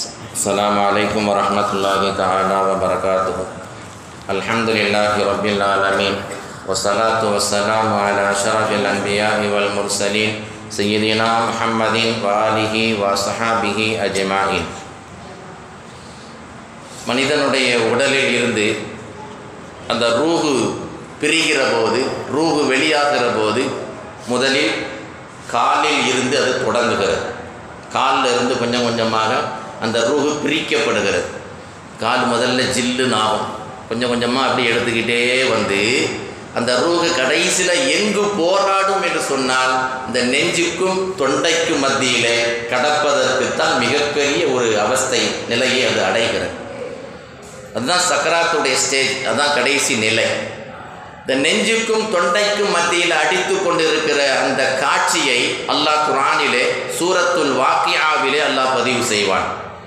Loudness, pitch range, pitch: -16 LUFS, 105-145 Hz, 115 Hz